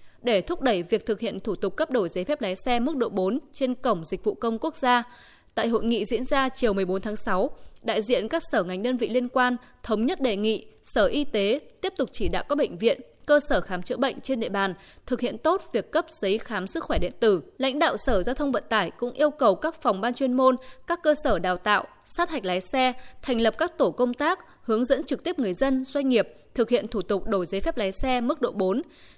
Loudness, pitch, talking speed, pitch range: -26 LUFS, 250 Hz, 255 wpm, 210-285 Hz